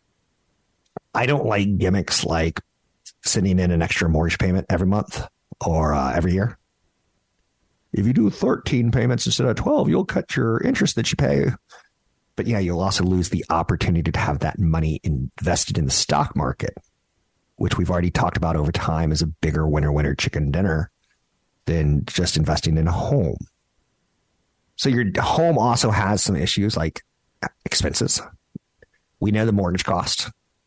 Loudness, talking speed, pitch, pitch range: -21 LUFS, 160 wpm, 90 Hz, 80-105 Hz